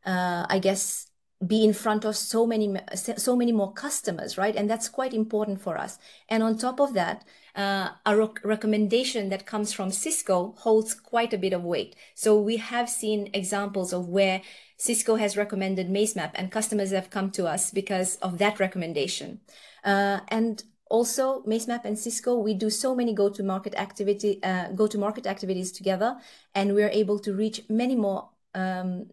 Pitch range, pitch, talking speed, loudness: 195-225 Hz, 210 Hz, 185 wpm, -26 LUFS